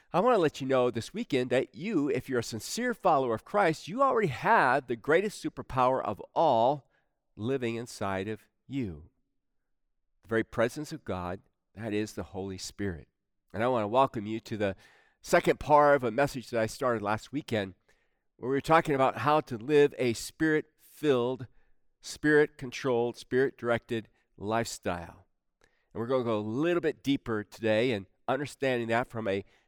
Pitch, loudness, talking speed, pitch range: 120 Hz, -29 LUFS, 170 wpm, 105-135 Hz